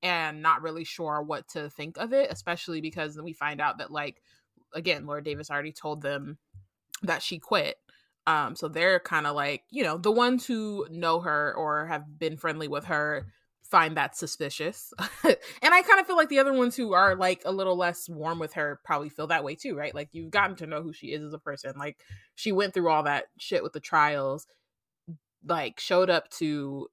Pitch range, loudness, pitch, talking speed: 150-180 Hz, -27 LUFS, 155 Hz, 215 wpm